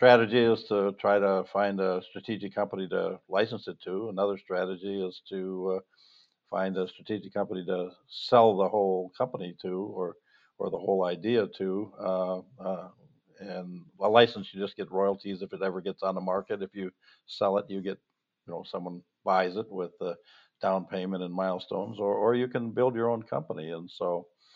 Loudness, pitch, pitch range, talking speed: -30 LUFS, 95 Hz, 90-100 Hz, 190 wpm